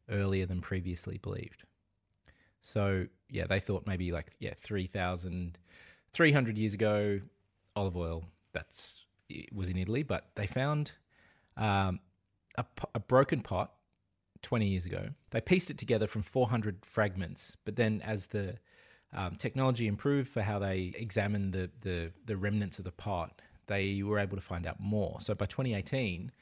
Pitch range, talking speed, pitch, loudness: 95-110 Hz, 155 wpm, 100 Hz, -34 LUFS